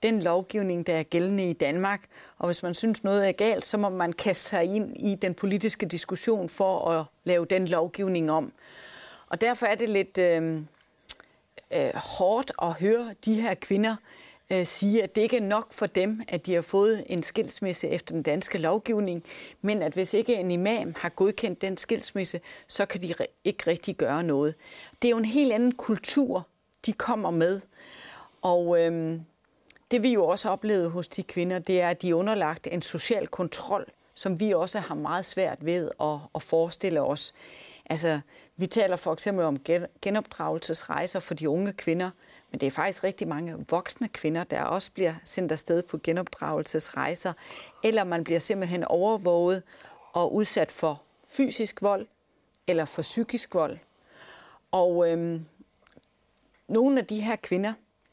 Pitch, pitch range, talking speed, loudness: 185 Hz, 170-215 Hz, 170 wpm, -28 LUFS